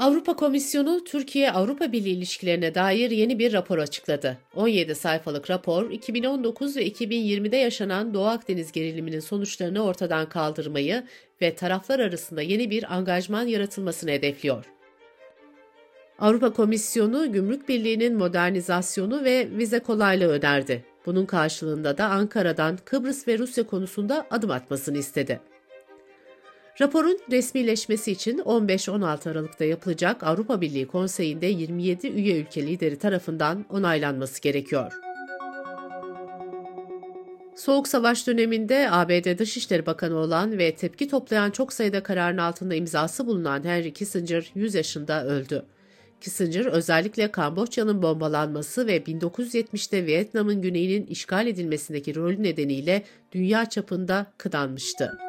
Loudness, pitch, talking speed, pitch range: -25 LUFS, 185 Hz, 110 wpm, 160-230 Hz